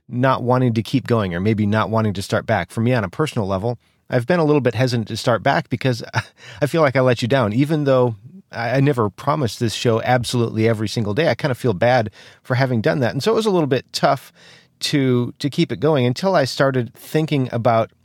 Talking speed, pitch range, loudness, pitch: 245 wpm, 115-140 Hz, -19 LUFS, 125 Hz